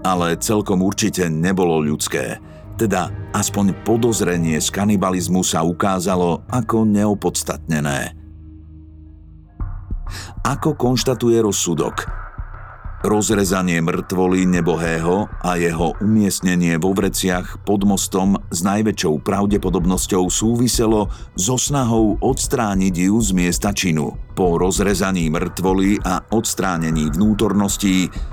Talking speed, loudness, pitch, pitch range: 95 wpm, -18 LUFS, 95 Hz, 85-105 Hz